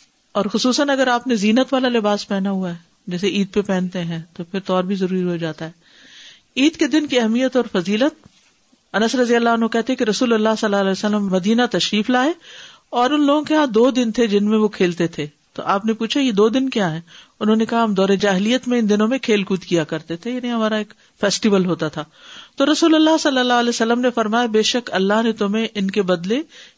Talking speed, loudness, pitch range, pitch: 240 wpm, -18 LUFS, 195-245 Hz, 220 Hz